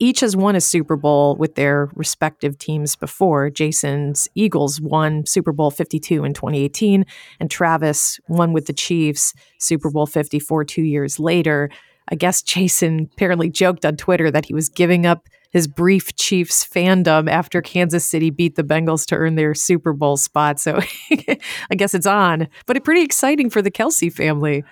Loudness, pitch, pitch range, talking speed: -17 LUFS, 160 Hz, 150-180 Hz, 175 wpm